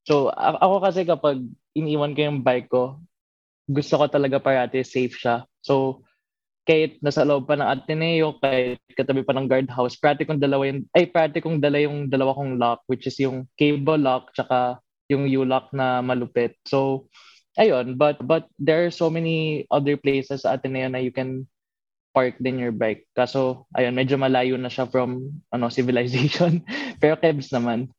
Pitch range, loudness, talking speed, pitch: 125-150 Hz, -22 LUFS, 170 wpm, 135 Hz